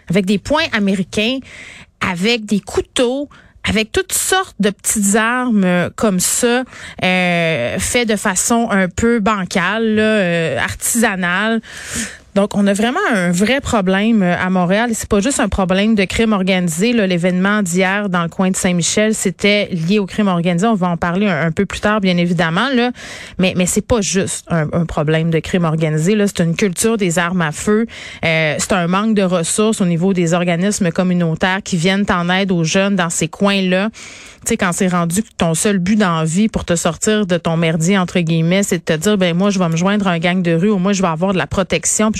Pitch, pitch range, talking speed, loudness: 195 Hz, 175-215 Hz, 210 wpm, -15 LUFS